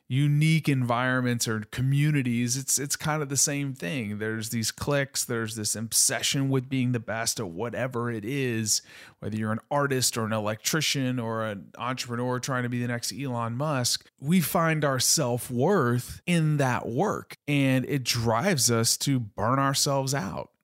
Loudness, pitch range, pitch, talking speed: -26 LUFS, 115-140 Hz, 125 Hz, 165 wpm